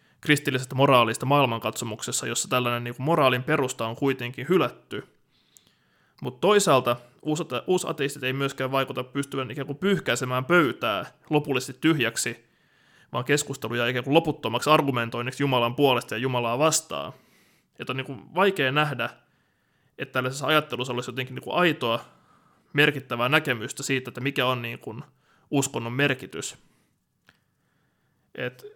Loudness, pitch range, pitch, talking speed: -25 LUFS, 125-150 Hz, 135 Hz, 125 wpm